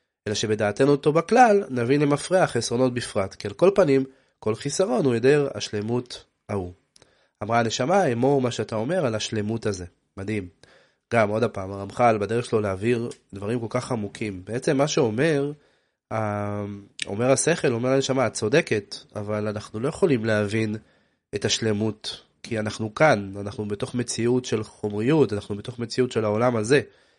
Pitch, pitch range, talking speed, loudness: 115 Hz, 105-135 Hz, 155 wpm, -24 LUFS